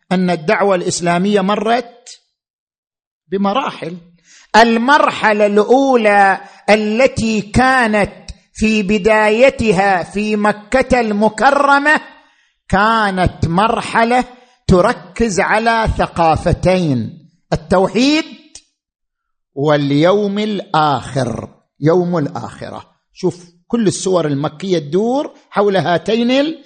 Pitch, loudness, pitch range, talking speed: 205 Hz, -14 LUFS, 175-235 Hz, 70 wpm